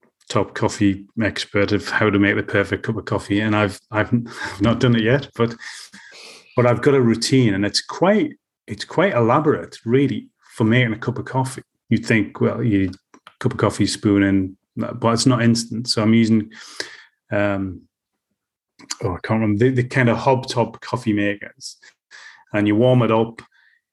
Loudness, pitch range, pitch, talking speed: -19 LUFS, 105-120 Hz, 115 Hz, 185 wpm